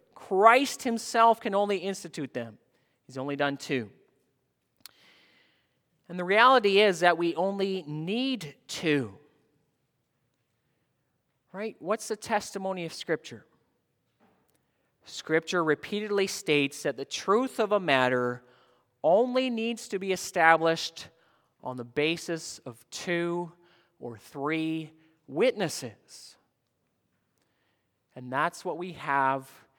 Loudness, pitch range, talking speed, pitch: -27 LUFS, 140-200 Hz, 105 wpm, 165 Hz